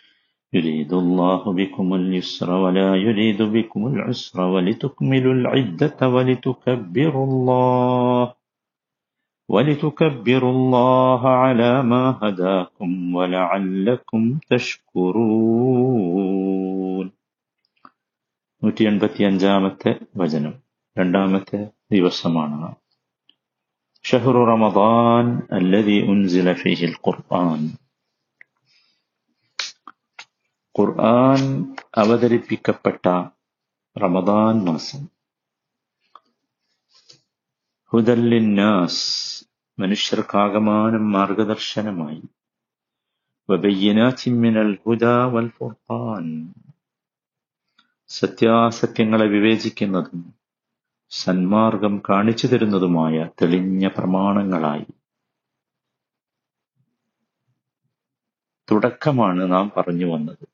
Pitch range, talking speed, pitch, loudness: 95-120 Hz, 45 wpm, 105 Hz, -19 LUFS